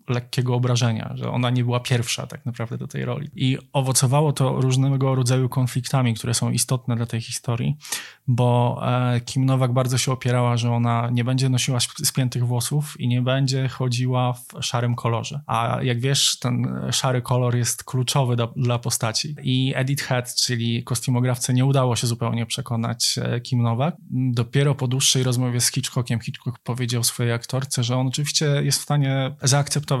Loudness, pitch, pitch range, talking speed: -22 LUFS, 125 Hz, 120-135 Hz, 170 wpm